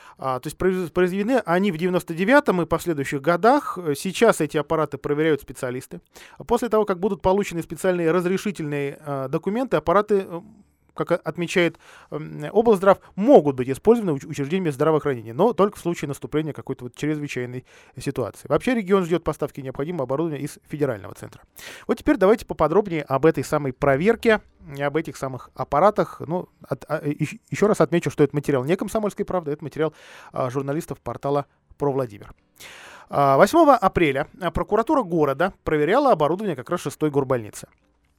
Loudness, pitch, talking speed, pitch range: -22 LUFS, 160 Hz, 150 wpm, 140-190 Hz